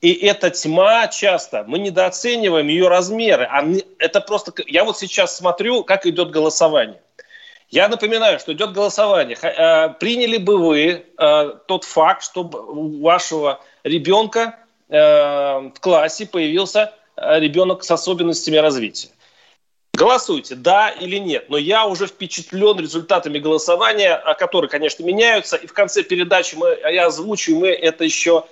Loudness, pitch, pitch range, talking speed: -16 LUFS, 185 Hz, 160-215 Hz, 130 wpm